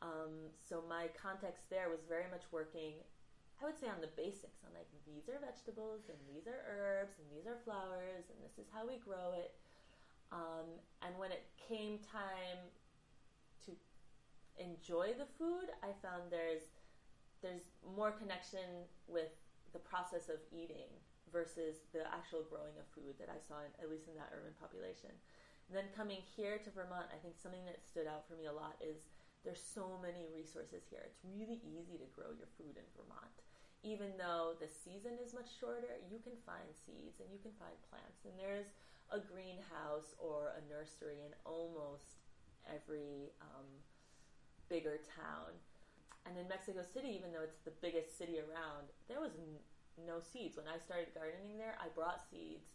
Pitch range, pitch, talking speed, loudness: 155-195 Hz, 170 Hz, 175 wpm, -49 LUFS